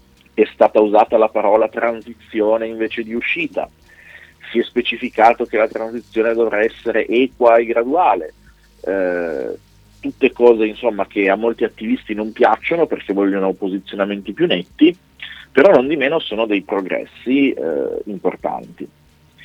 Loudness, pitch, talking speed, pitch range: -17 LUFS, 115 Hz, 135 wpm, 100-120 Hz